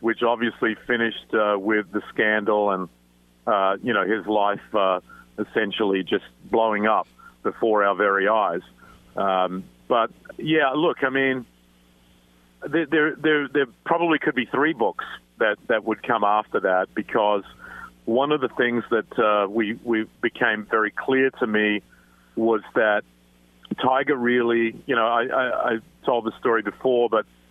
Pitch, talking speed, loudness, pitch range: 110 Hz, 155 wpm, -23 LUFS, 95-130 Hz